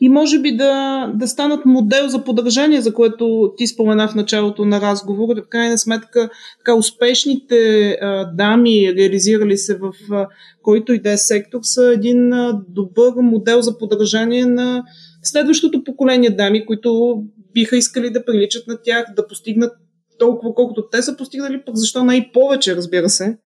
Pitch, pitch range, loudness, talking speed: 230 Hz, 210-245 Hz, -15 LUFS, 165 wpm